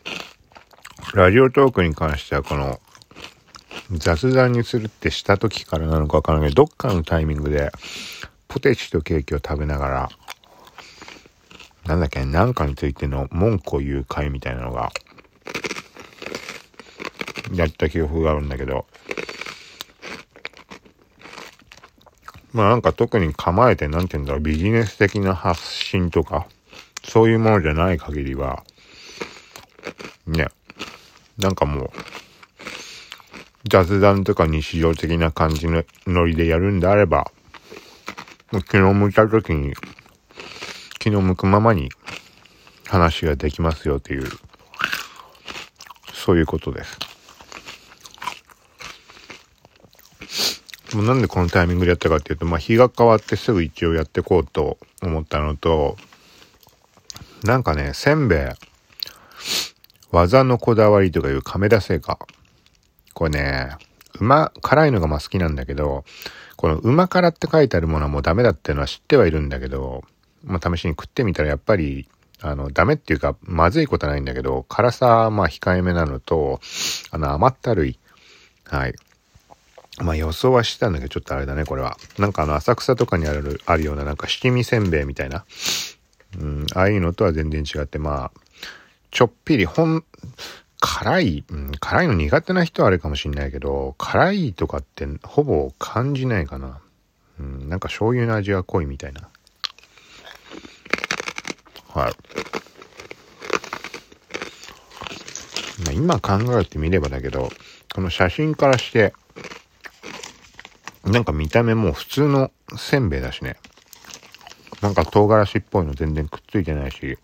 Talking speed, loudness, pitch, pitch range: 285 characters per minute, -20 LUFS, 85 Hz, 75-105 Hz